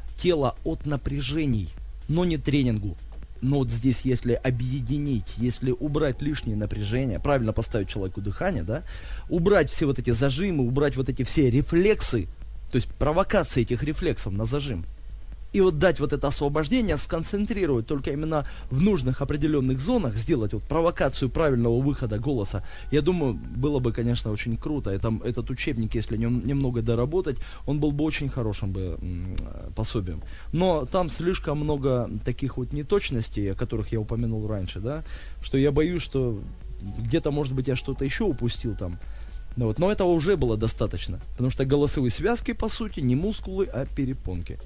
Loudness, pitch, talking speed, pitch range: -25 LUFS, 130 Hz, 160 wpm, 110-150 Hz